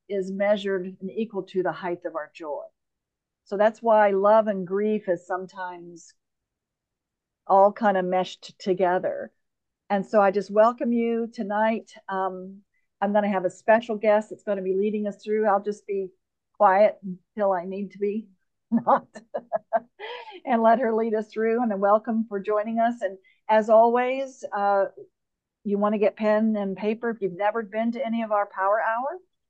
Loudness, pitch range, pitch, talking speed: -24 LUFS, 195-225 Hz, 210 Hz, 180 wpm